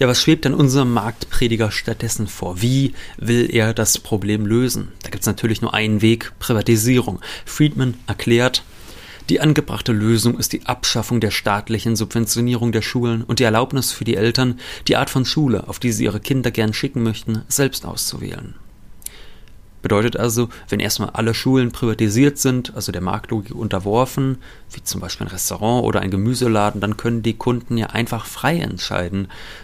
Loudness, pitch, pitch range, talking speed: -19 LUFS, 115 Hz, 105-125 Hz, 170 wpm